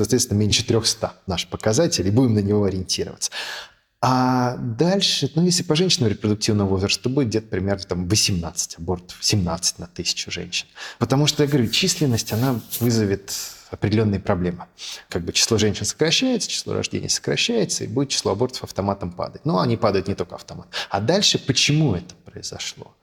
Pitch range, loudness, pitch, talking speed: 100-140 Hz, -21 LUFS, 115 Hz, 165 wpm